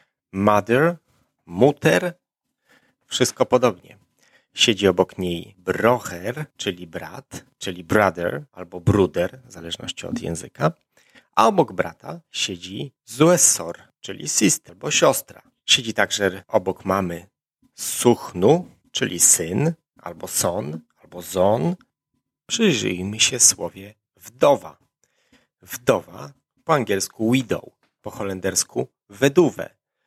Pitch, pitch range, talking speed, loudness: 105 Hz, 95-130 Hz, 100 wpm, -20 LUFS